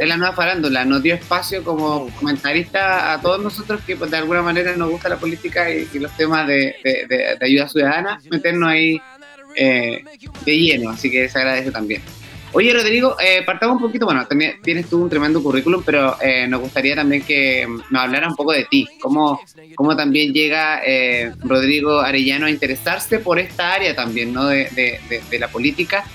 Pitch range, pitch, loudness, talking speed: 135-175 Hz, 155 Hz, -17 LUFS, 195 wpm